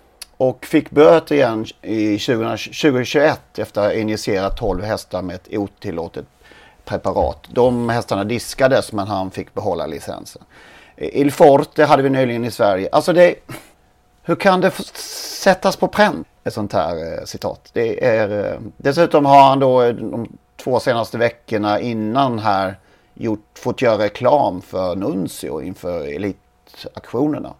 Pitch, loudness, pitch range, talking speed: 125 Hz, -18 LUFS, 110-155 Hz, 140 wpm